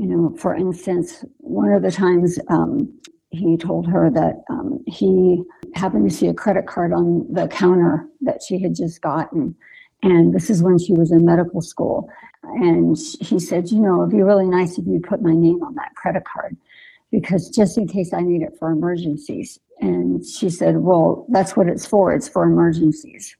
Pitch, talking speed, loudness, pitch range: 180 Hz, 195 wpm, -18 LUFS, 170-205 Hz